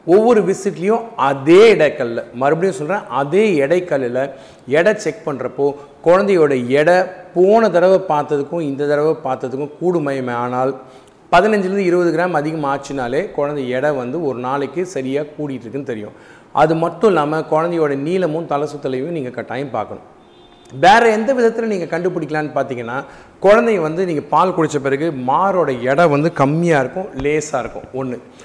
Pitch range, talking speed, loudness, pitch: 135-180 Hz, 135 wpm, -16 LUFS, 150 Hz